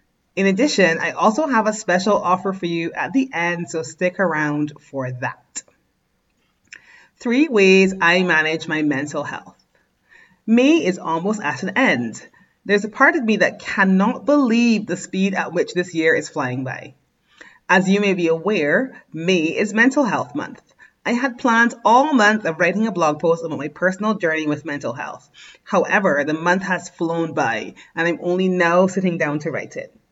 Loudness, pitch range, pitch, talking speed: -18 LUFS, 165-215 Hz, 180 Hz, 180 wpm